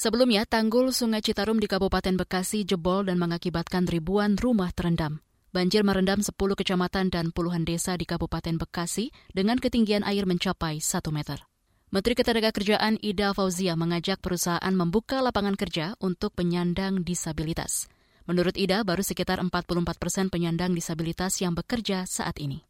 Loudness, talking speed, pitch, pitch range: -26 LUFS, 140 wpm, 185 Hz, 175-205 Hz